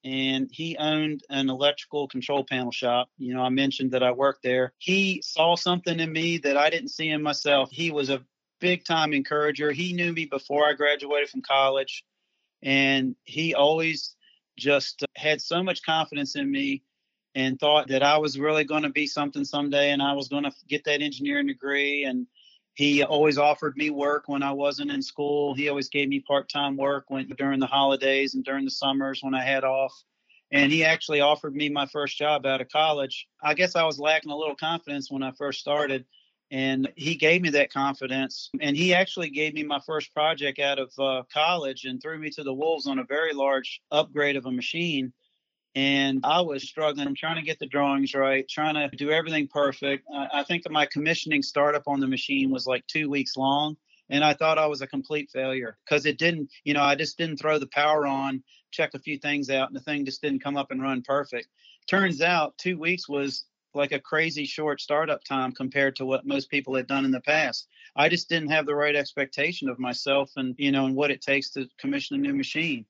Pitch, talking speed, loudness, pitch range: 145 Hz, 215 wpm, -25 LUFS, 135-155 Hz